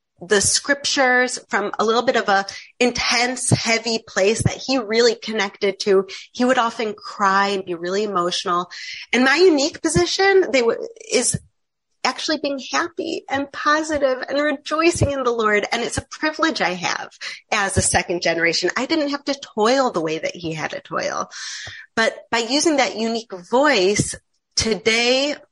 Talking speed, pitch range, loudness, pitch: 165 wpm, 200-290 Hz, -19 LUFS, 245 Hz